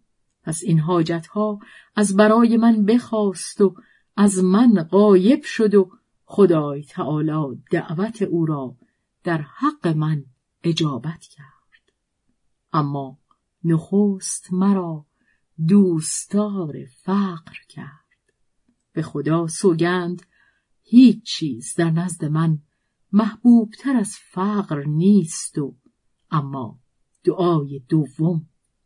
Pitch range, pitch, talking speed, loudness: 155-205 Hz, 175 Hz, 100 wpm, -20 LUFS